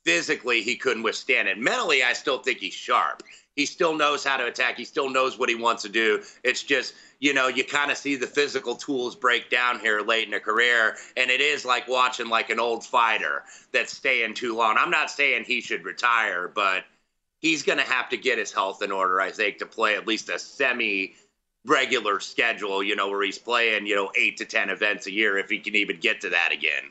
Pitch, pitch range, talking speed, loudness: 125 Hz, 115-145 Hz, 230 wpm, -23 LUFS